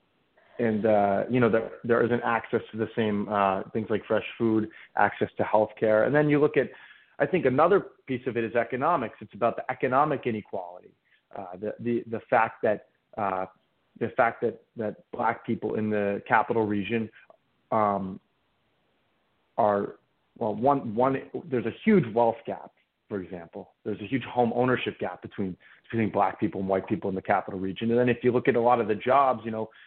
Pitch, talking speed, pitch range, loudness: 115 Hz, 195 wpm, 105-125 Hz, -27 LUFS